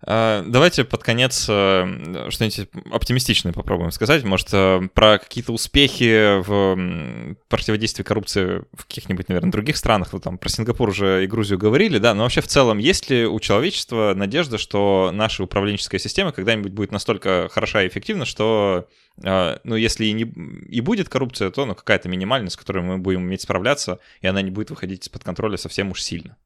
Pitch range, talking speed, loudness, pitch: 95-115 Hz, 170 wpm, -20 LUFS, 105 Hz